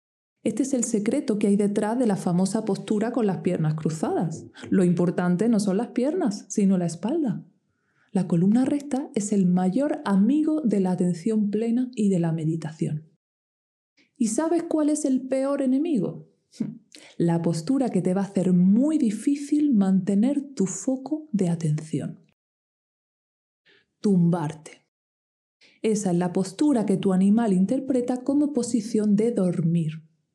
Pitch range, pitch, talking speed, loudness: 185-260 Hz, 215 Hz, 145 wpm, -24 LUFS